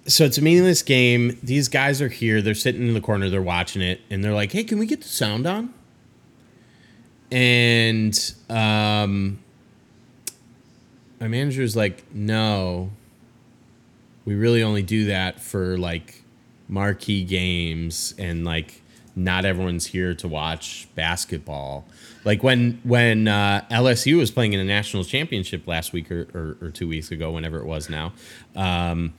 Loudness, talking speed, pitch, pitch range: -22 LUFS, 155 wpm, 105 Hz, 90-120 Hz